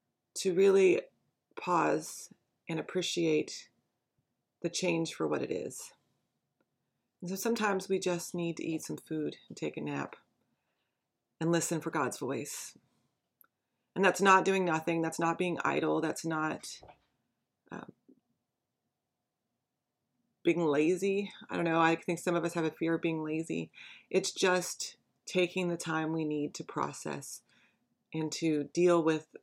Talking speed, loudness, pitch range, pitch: 145 wpm, -32 LUFS, 160-185 Hz, 170 Hz